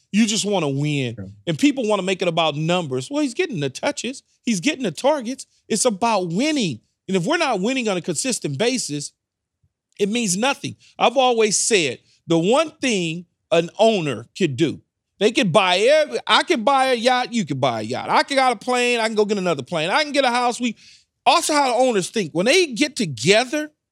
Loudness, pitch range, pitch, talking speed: -20 LUFS, 170-255 Hz, 215 Hz, 220 wpm